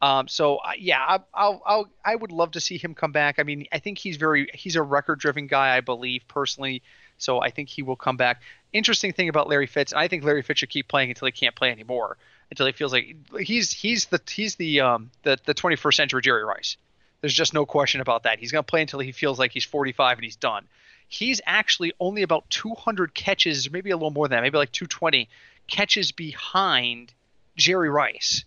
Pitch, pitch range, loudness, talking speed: 150 Hz, 135-180 Hz, -23 LUFS, 230 wpm